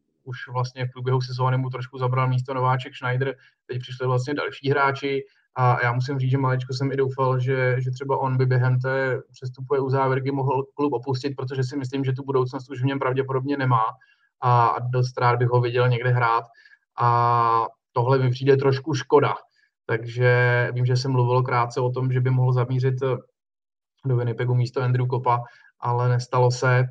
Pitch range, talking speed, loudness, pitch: 125-135 Hz, 185 wpm, -23 LUFS, 130 Hz